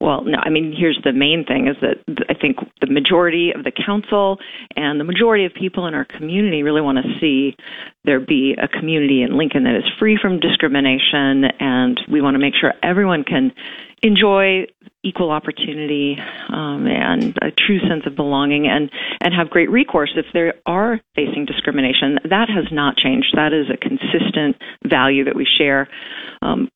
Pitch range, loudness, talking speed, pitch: 140-200 Hz, -17 LUFS, 180 wpm, 155 Hz